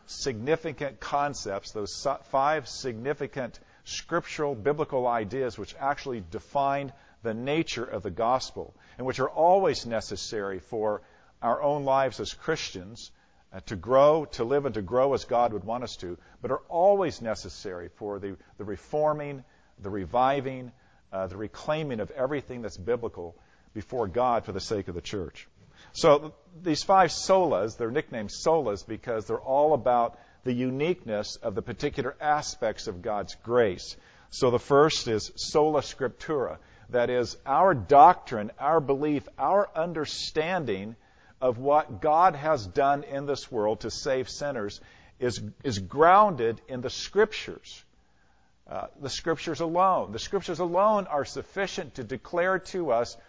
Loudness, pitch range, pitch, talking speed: -27 LUFS, 110-155 Hz, 135 Hz, 145 wpm